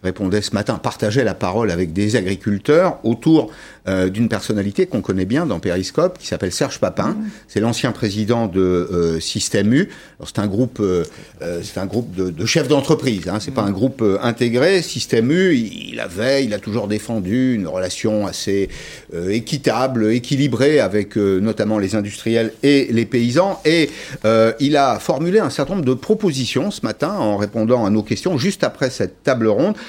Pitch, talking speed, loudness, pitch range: 115 Hz, 185 wpm, -18 LUFS, 100-135 Hz